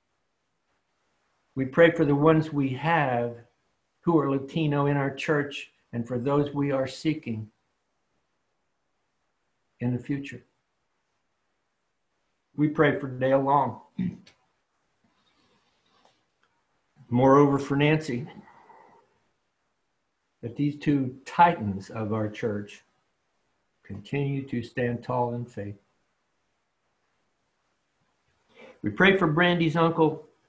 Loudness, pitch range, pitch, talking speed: -25 LUFS, 120-155 Hz, 140 Hz, 95 wpm